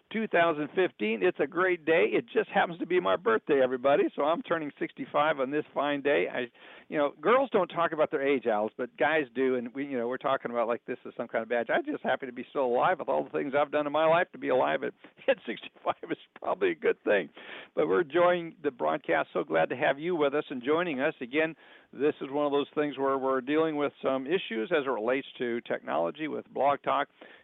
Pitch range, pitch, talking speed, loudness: 135-170 Hz, 145 Hz, 245 wpm, -29 LUFS